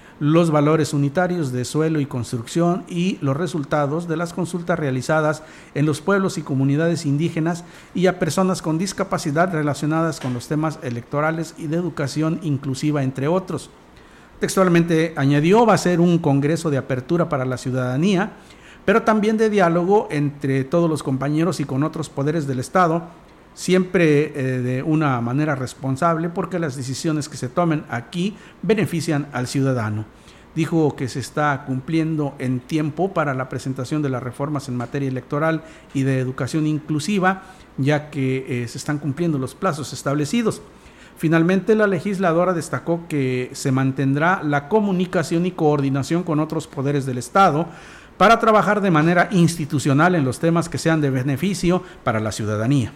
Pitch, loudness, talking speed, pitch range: 155 Hz, -20 LUFS, 155 wpm, 140-175 Hz